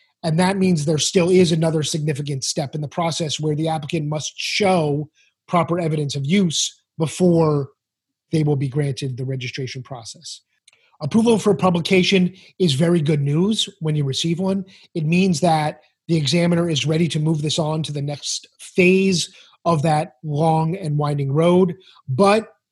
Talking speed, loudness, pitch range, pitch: 165 wpm, -20 LUFS, 150-180 Hz, 160 Hz